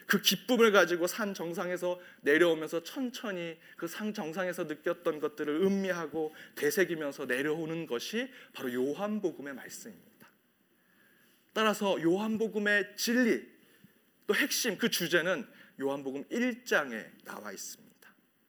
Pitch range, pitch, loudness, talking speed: 160-215 Hz, 180 Hz, -31 LUFS, 285 characters per minute